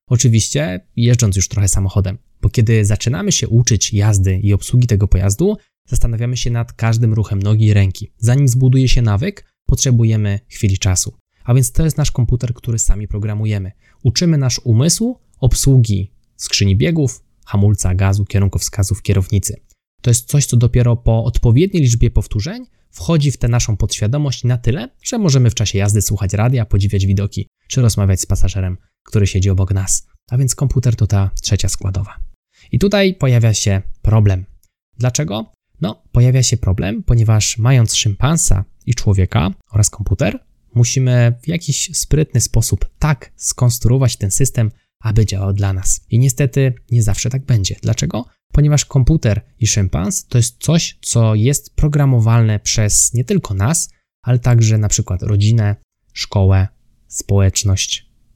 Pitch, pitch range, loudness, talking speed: 115 Hz, 100-125 Hz, -15 LUFS, 150 wpm